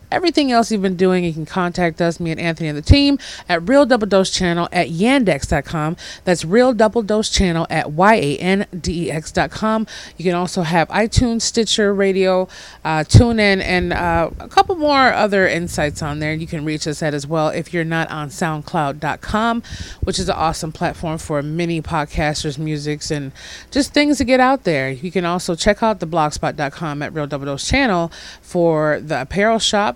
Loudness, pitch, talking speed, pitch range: -18 LUFS, 175 Hz, 185 wpm, 155-210 Hz